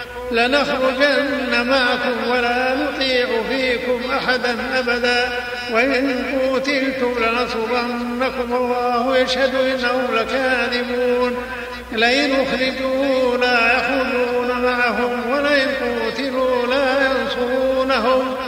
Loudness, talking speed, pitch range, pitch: -18 LUFS, 75 wpm, 245-260 Hz, 250 Hz